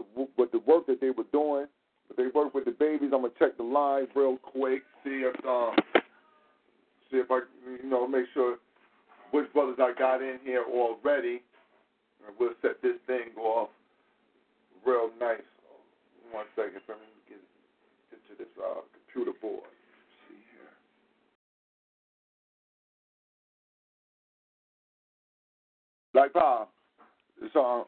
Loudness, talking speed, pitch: -29 LUFS, 125 wpm, 135 Hz